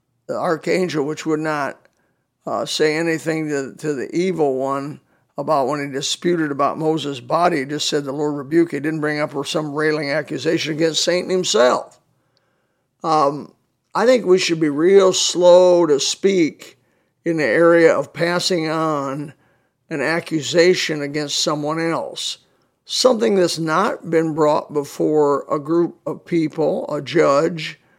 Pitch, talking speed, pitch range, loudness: 160 Hz, 150 wpm, 150-175 Hz, -18 LUFS